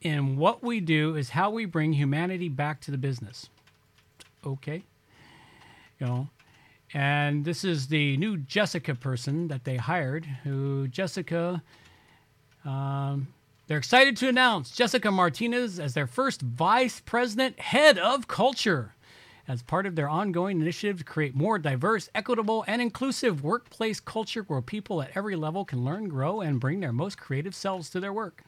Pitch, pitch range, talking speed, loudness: 160 Hz, 140-210 Hz, 160 wpm, -27 LUFS